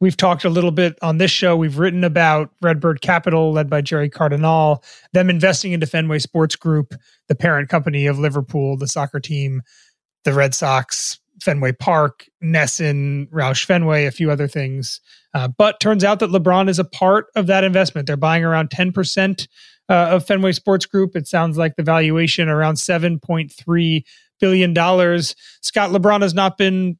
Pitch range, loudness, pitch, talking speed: 150-185 Hz, -17 LUFS, 165 Hz, 170 wpm